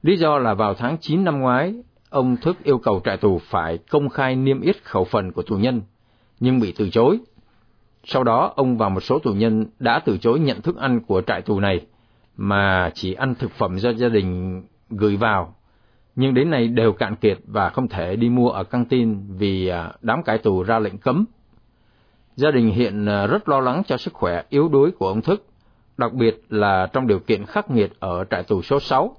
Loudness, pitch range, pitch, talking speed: -20 LUFS, 100-130 Hz, 115 Hz, 215 wpm